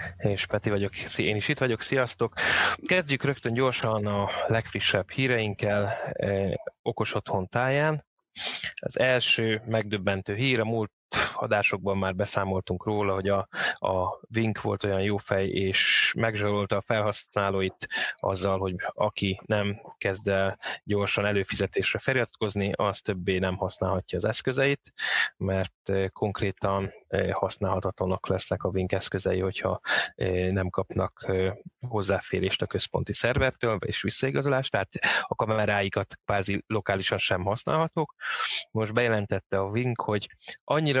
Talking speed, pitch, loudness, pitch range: 125 wpm, 100 Hz, -27 LUFS, 95-115 Hz